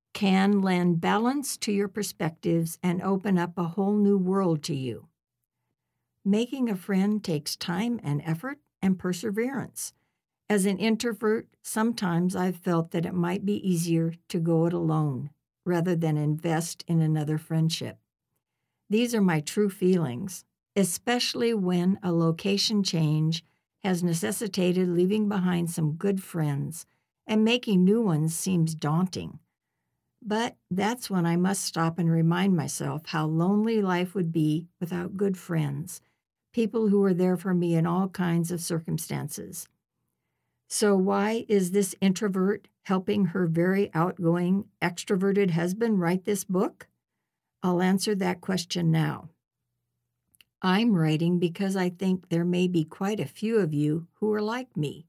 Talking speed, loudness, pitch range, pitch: 145 wpm, -27 LUFS, 165-200 Hz, 180 Hz